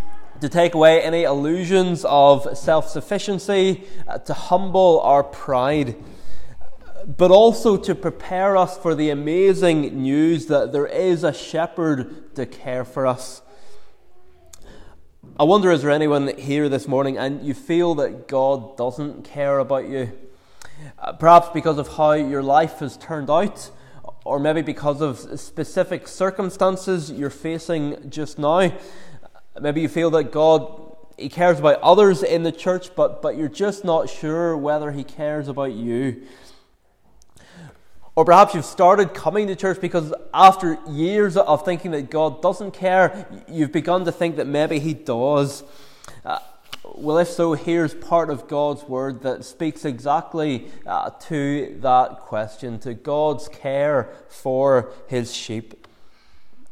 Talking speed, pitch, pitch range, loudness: 145 wpm, 155 Hz, 140-175 Hz, -19 LUFS